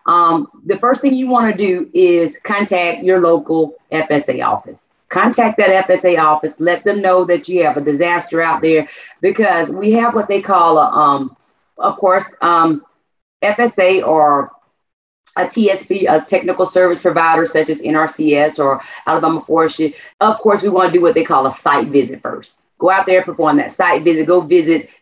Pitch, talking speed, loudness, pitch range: 180 Hz, 180 wpm, -14 LUFS, 160-200 Hz